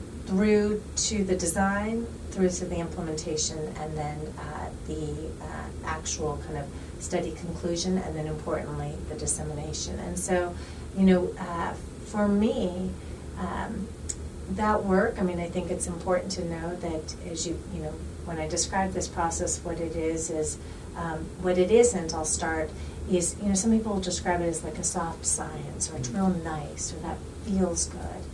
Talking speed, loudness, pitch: 175 wpm, -29 LUFS, 170 Hz